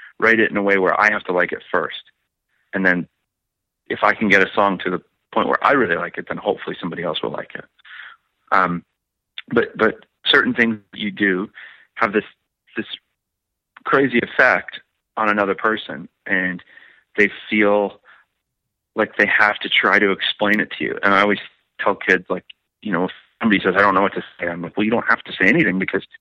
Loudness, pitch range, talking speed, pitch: -18 LUFS, 95-105 Hz, 205 wpm, 100 Hz